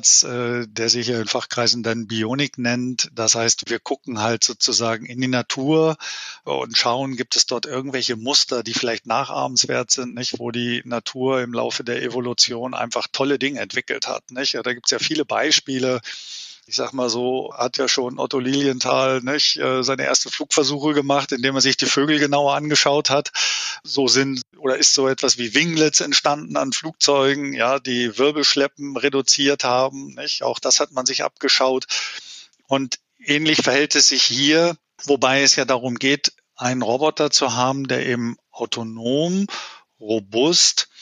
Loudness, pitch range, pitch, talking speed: -19 LUFS, 120-140 Hz, 130 Hz, 165 wpm